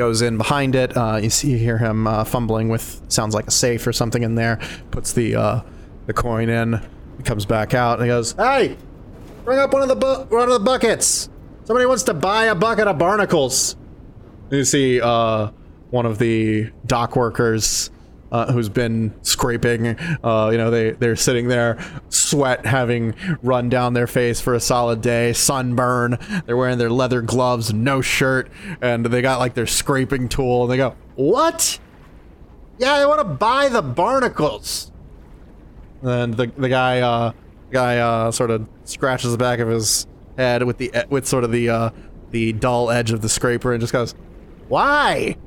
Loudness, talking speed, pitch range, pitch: -19 LUFS, 185 wpm, 115-130 Hz, 120 Hz